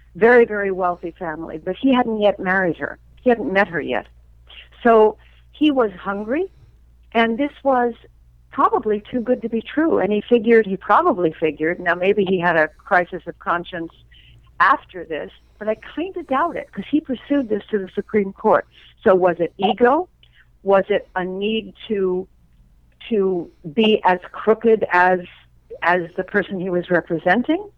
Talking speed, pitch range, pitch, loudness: 170 wpm, 175-230 Hz, 195 Hz, -19 LUFS